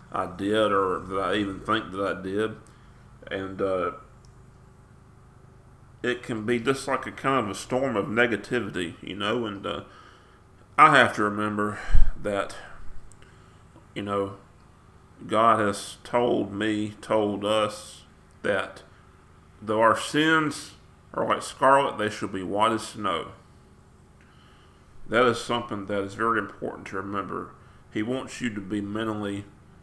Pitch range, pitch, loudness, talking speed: 95-120 Hz, 105 Hz, -26 LUFS, 140 wpm